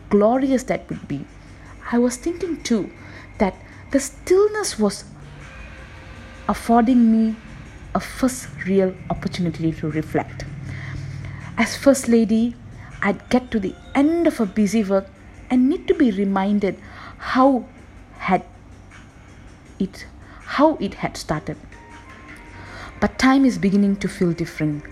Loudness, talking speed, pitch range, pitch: -21 LUFS, 125 wpm, 150-250 Hz, 200 Hz